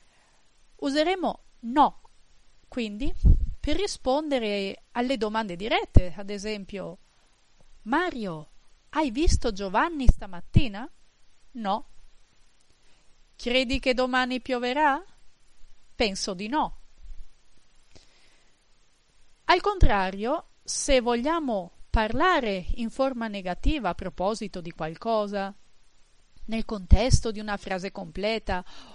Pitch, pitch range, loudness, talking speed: 225 Hz, 200-270 Hz, -27 LUFS, 85 wpm